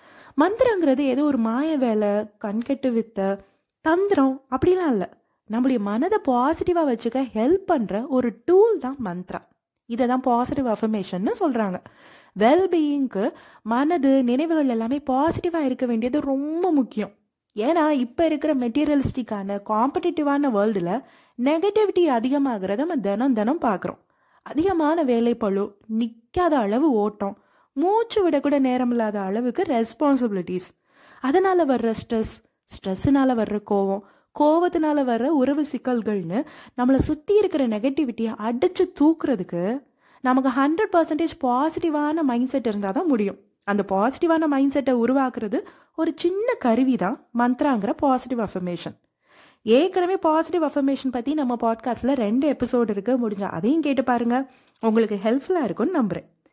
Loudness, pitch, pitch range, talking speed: -22 LUFS, 260 Hz, 225-310 Hz, 100 wpm